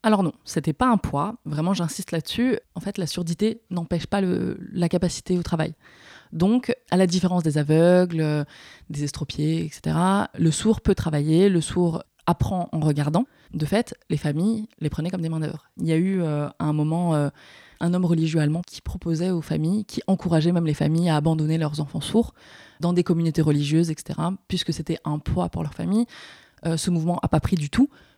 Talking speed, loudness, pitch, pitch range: 200 wpm, -24 LUFS, 170 Hz, 155-185 Hz